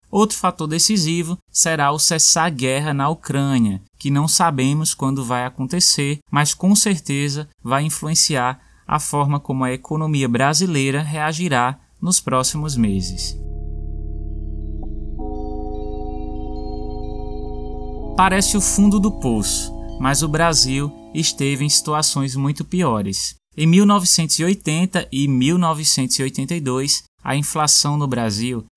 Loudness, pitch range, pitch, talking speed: -17 LUFS, 110-160 Hz, 140 Hz, 110 wpm